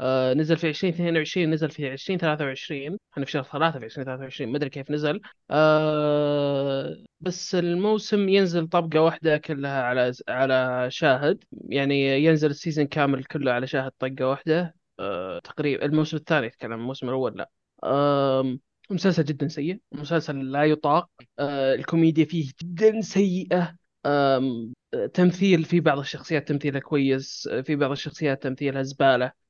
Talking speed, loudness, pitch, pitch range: 125 wpm, -24 LUFS, 150 Hz, 135-165 Hz